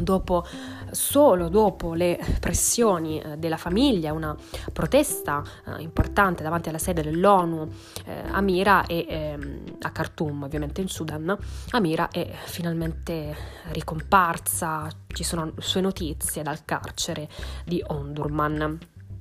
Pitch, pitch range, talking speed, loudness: 160 Hz, 150-185 Hz, 110 wpm, -25 LUFS